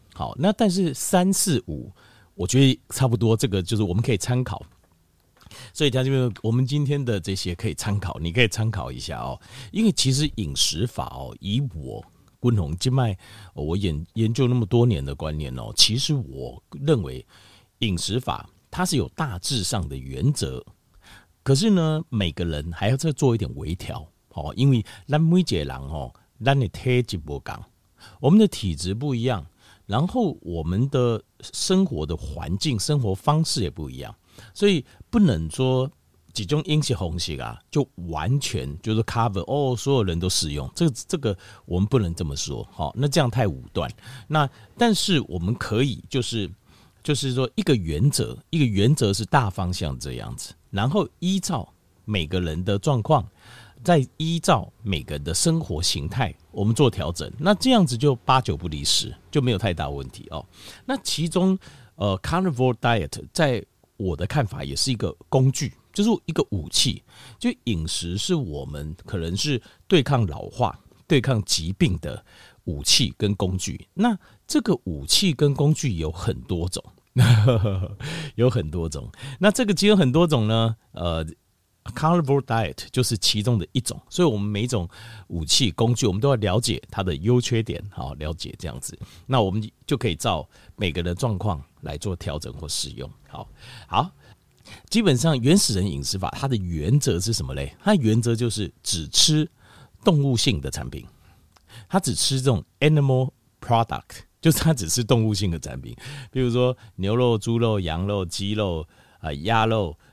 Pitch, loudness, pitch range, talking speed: 115 Hz, -23 LUFS, 95-140 Hz, 270 characters per minute